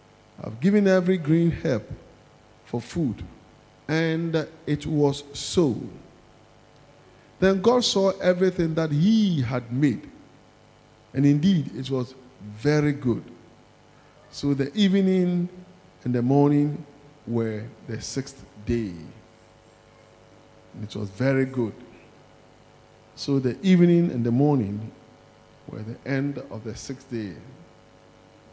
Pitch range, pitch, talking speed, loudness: 110-155 Hz, 135 Hz, 110 wpm, -24 LUFS